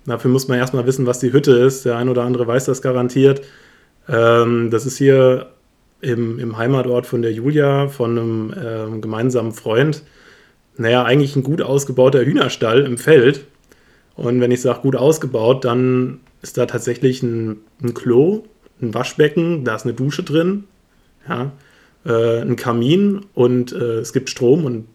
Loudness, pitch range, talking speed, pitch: -17 LUFS, 120-135 Hz, 150 wpm, 125 Hz